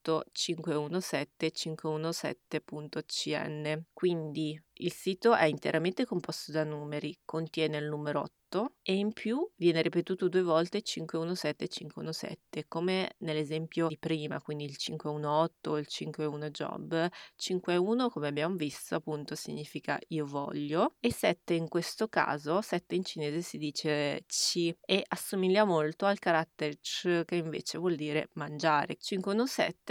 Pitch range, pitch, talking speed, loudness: 150-180 Hz, 160 Hz, 130 wpm, -33 LUFS